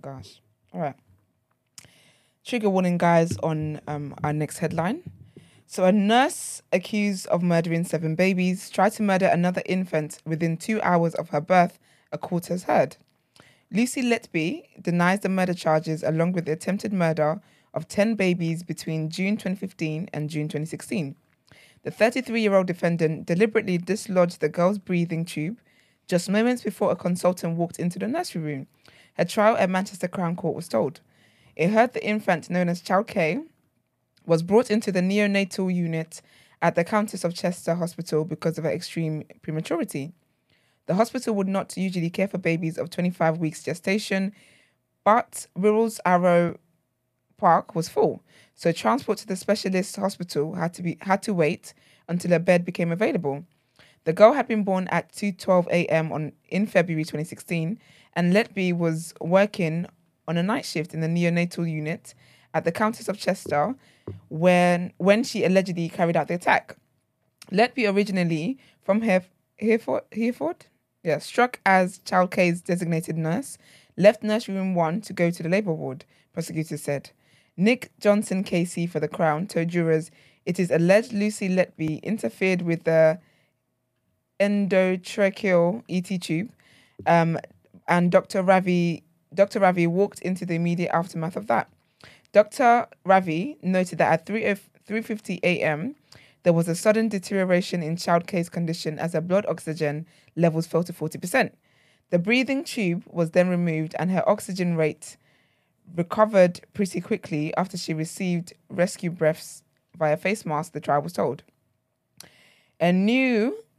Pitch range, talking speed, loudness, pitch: 160-195 Hz, 150 wpm, -24 LUFS, 175 Hz